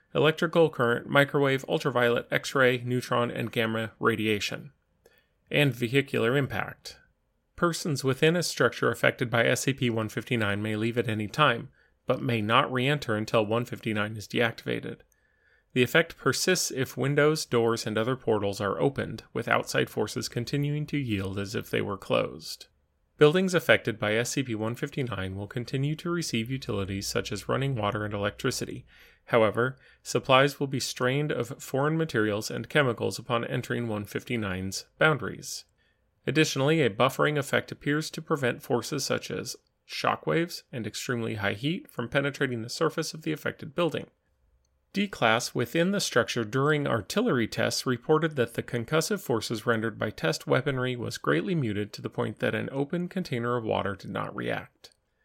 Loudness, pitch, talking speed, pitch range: -28 LUFS, 125 Hz, 155 wpm, 110-145 Hz